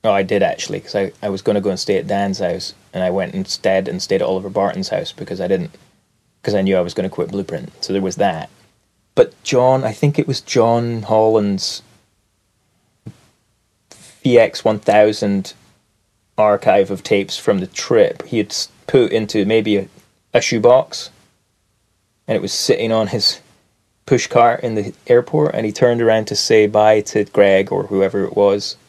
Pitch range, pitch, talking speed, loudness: 105-120 Hz, 110 Hz, 185 wpm, -17 LUFS